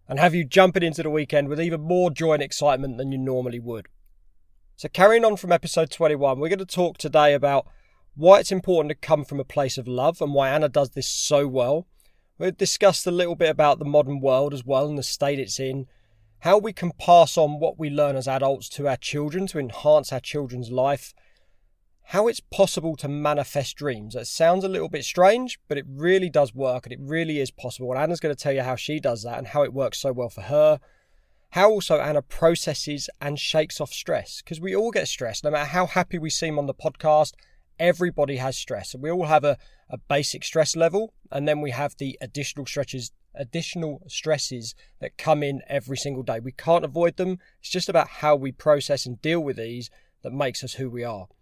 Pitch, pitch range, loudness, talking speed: 145 Hz, 135-165 Hz, -23 LUFS, 220 wpm